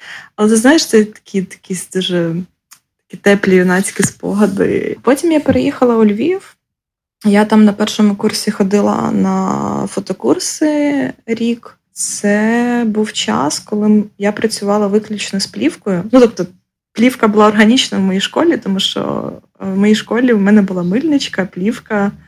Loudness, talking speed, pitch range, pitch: -14 LUFS, 140 wpm, 200-235 Hz, 210 Hz